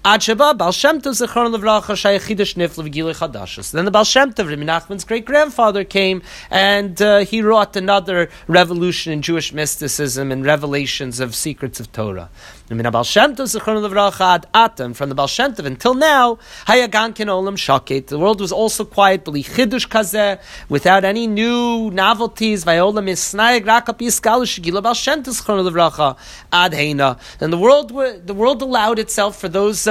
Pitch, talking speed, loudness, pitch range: 200 Hz, 90 wpm, -16 LUFS, 160-225 Hz